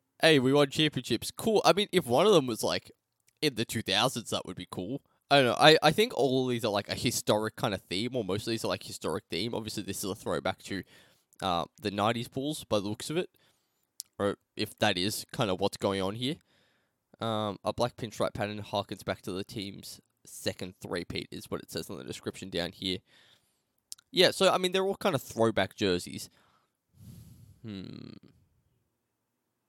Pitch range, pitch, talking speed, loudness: 100-130 Hz, 115 Hz, 205 wpm, -29 LUFS